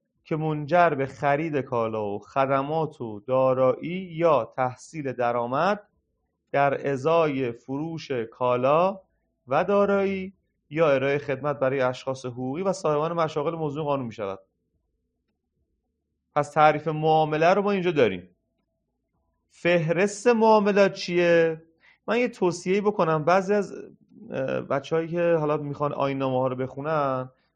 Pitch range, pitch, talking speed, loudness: 130-170 Hz, 145 Hz, 120 wpm, -24 LUFS